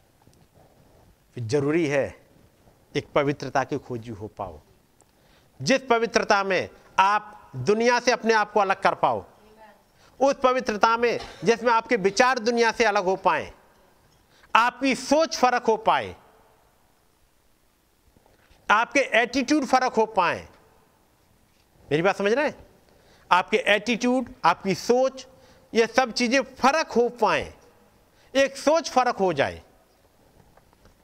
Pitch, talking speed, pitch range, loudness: 220 Hz, 120 wpm, 175-250 Hz, -23 LUFS